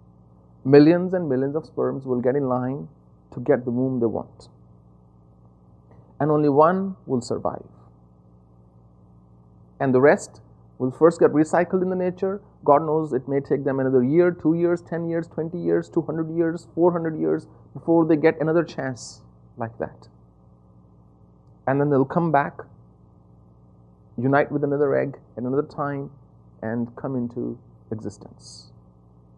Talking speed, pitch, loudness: 150 wpm, 125 Hz, -22 LUFS